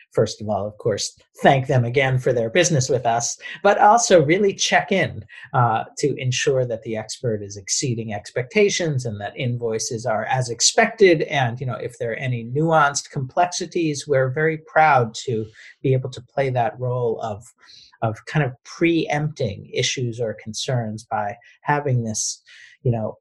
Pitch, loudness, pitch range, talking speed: 130 Hz, -21 LUFS, 115-155 Hz, 170 wpm